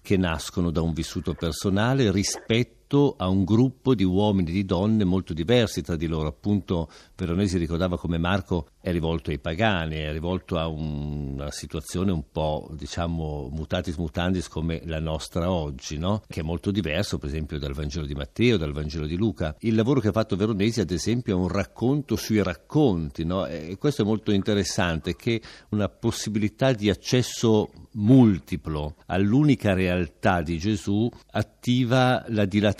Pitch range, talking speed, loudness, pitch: 80-105 Hz, 165 wpm, -25 LUFS, 90 Hz